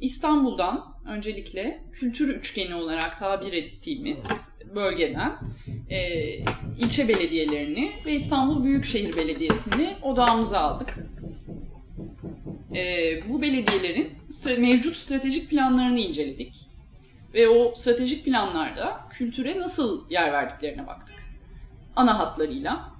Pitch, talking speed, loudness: 225 Hz, 85 wpm, -25 LUFS